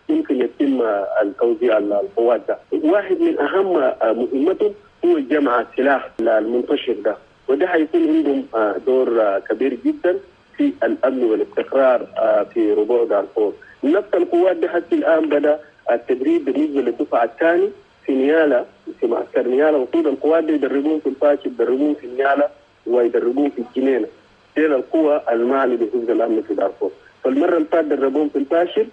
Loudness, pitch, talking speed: -18 LUFS, 225 Hz, 135 wpm